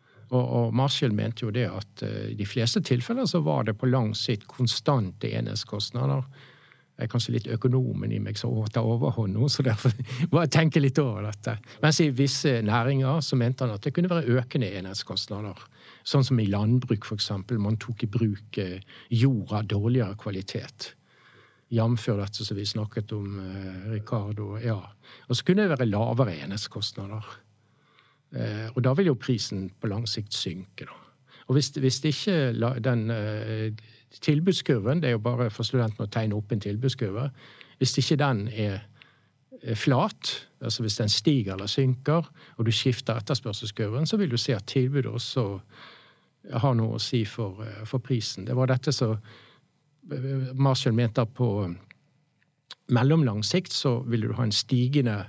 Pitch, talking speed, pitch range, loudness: 120 Hz, 165 wpm, 110-135 Hz, -27 LUFS